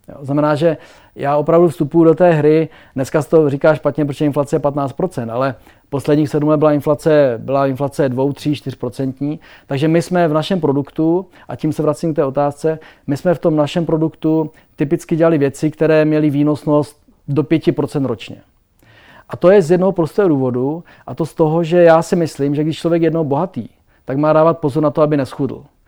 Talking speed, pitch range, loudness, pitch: 195 wpm, 140-160 Hz, -16 LUFS, 150 Hz